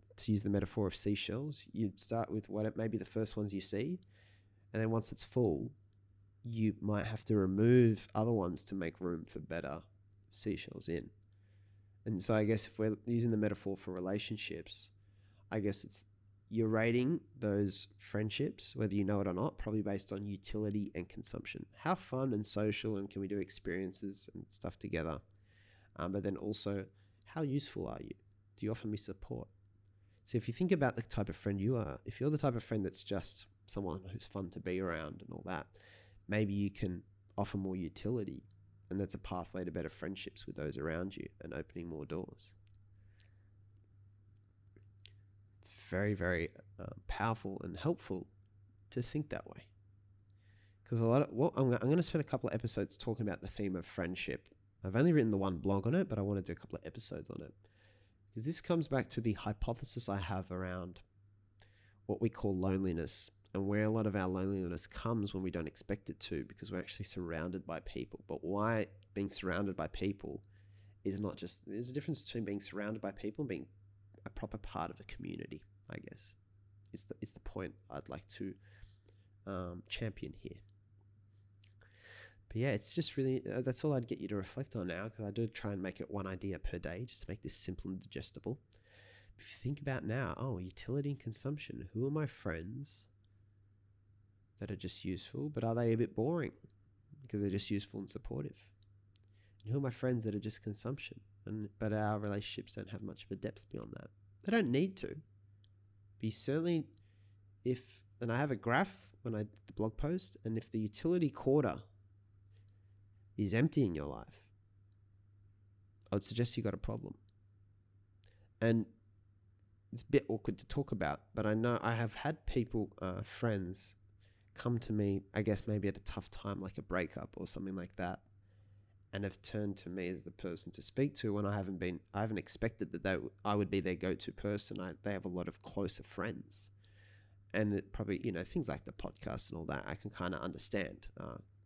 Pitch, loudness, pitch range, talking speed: 100 Hz, -39 LUFS, 100-110 Hz, 195 wpm